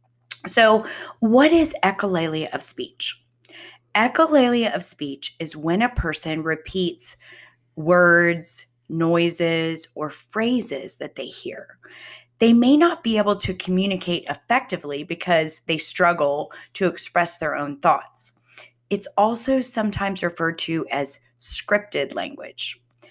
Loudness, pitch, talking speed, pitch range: -21 LUFS, 170 Hz, 115 wpm, 155-210 Hz